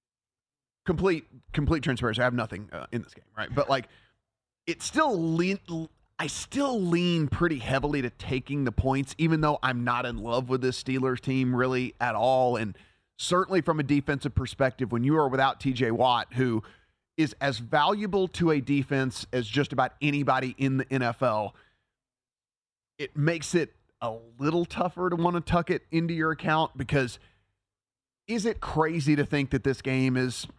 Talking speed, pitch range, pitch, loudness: 175 wpm, 120-155 Hz, 135 Hz, -27 LUFS